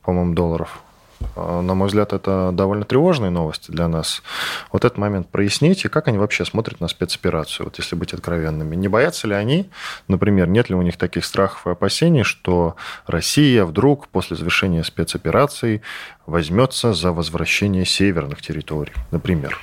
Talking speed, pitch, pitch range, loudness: 155 wpm, 95 Hz, 85-105 Hz, -19 LUFS